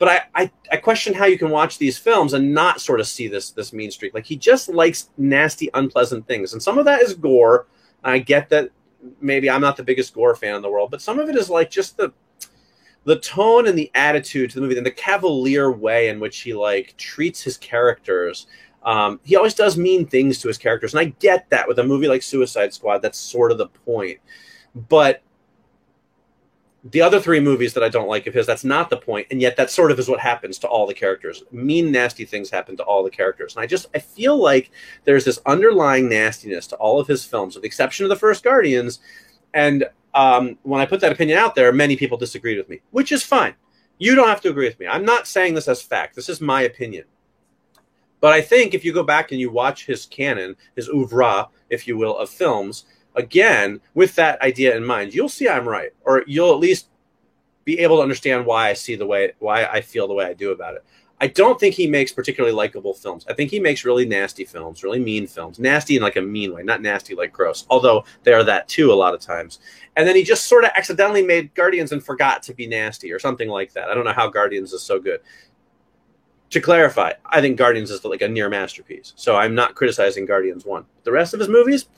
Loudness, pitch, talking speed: -18 LUFS, 185 Hz, 235 wpm